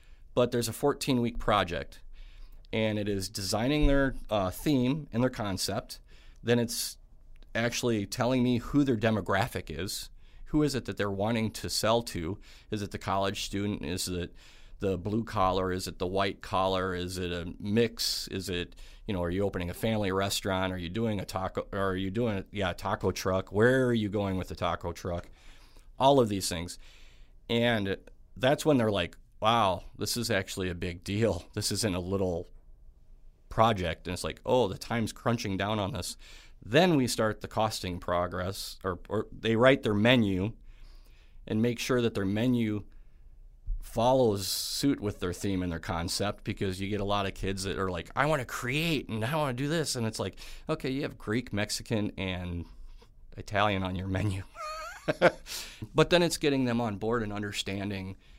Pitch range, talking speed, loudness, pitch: 95-115 Hz, 185 wpm, -30 LUFS, 100 Hz